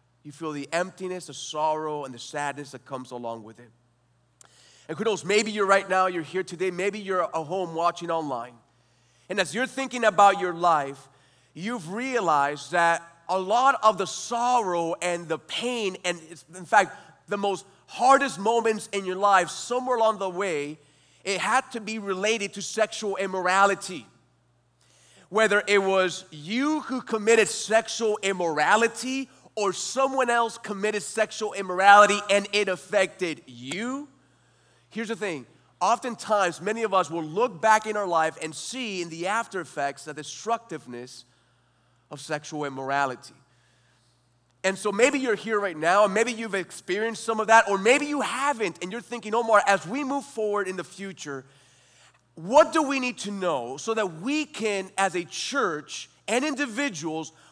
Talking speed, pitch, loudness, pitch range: 165 wpm, 190 Hz, -25 LUFS, 155-220 Hz